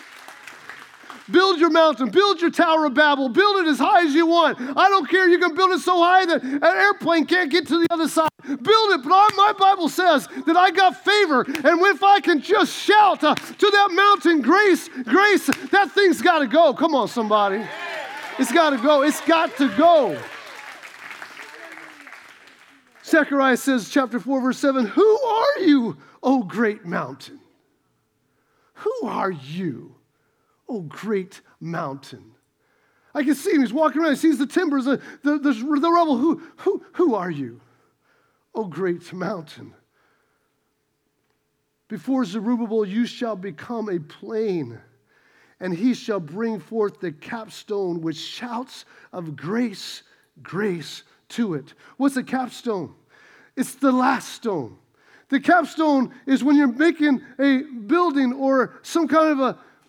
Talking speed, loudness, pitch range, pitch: 155 wpm, -19 LUFS, 220-340 Hz, 280 Hz